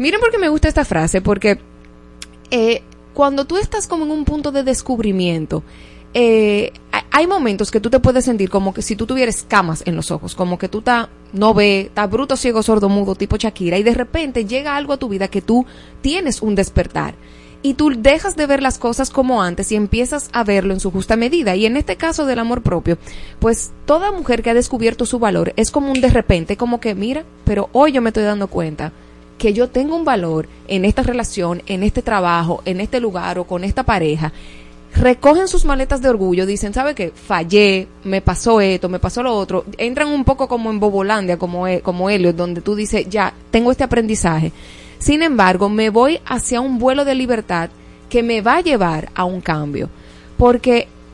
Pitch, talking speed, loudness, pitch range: 220 Hz, 205 wpm, -16 LUFS, 185-255 Hz